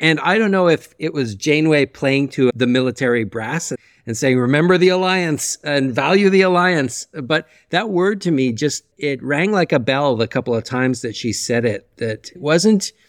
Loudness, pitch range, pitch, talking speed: -17 LUFS, 125-175 Hz, 145 Hz, 195 wpm